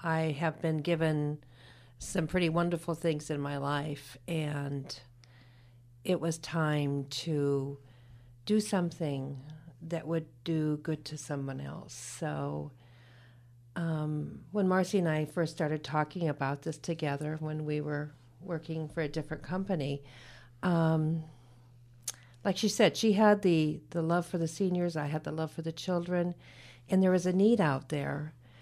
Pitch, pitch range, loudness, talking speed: 155 Hz, 135-170 Hz, -32 LUFS, 150 wpm